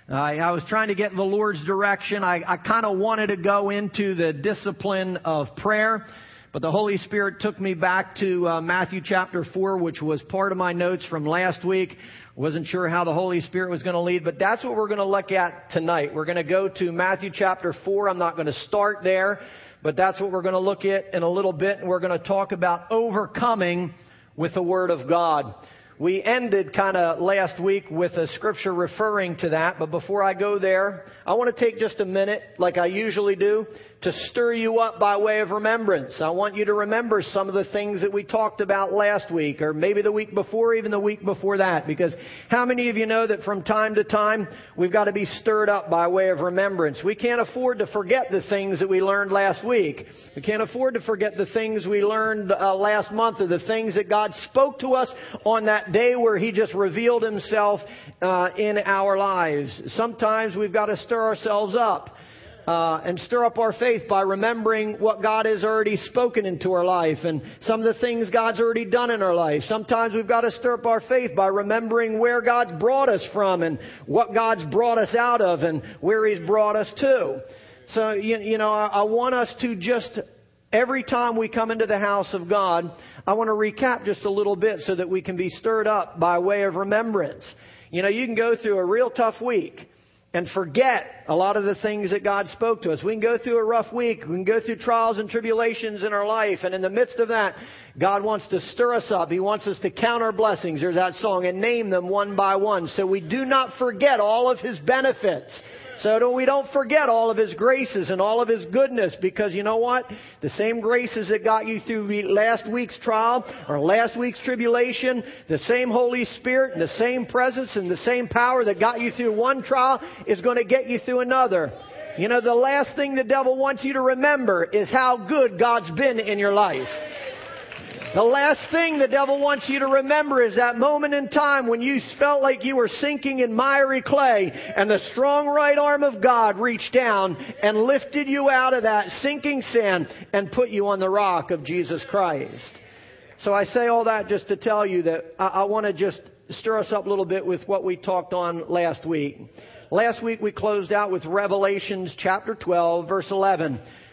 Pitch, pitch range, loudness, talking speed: 210 Hz, 185-230 Hz, -22 LUFS, 220 wpm